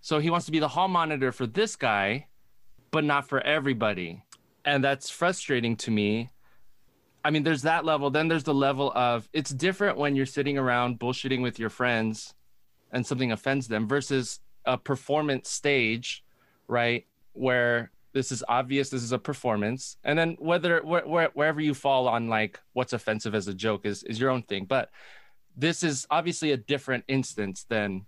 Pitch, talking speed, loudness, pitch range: 135 Hz, 180 wpm, -27 LUFS, 120-150 Hz